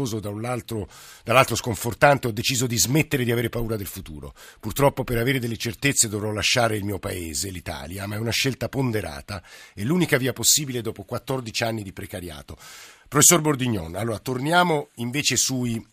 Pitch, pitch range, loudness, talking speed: 115 Hz, 105-130 Hz, -22 LUFS, 160 wpm